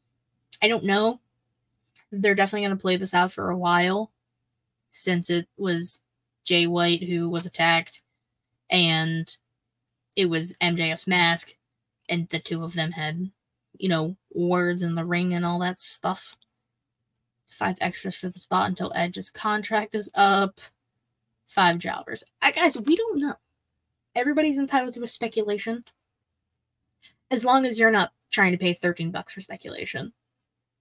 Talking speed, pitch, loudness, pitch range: 150 wpm, 175 Hz, -24 LUFS, 125-200 Hz